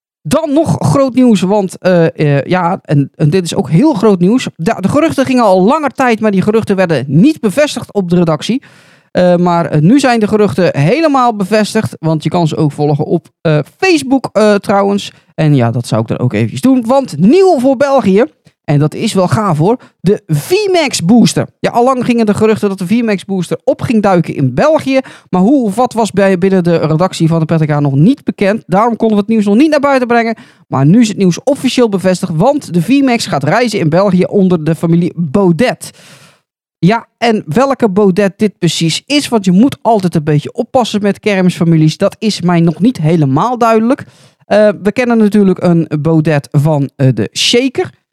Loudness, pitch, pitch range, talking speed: -11 LUFS, 195 Hz, 165-235 Hz, 205 wpm